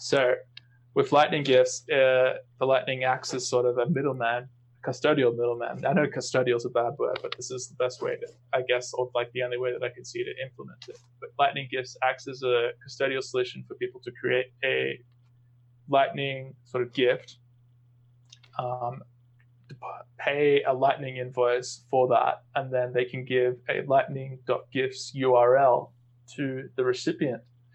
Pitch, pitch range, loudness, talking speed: 125 Hz, 120-135 Hz, -27 LUFS, 170 wpm